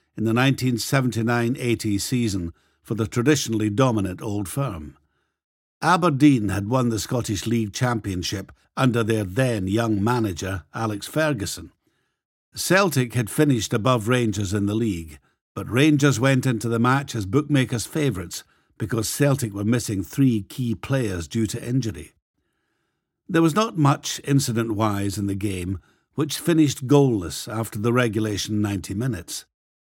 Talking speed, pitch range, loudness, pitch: 140 wpm, 100-130 Hz, -22 LUFS, 115 Hz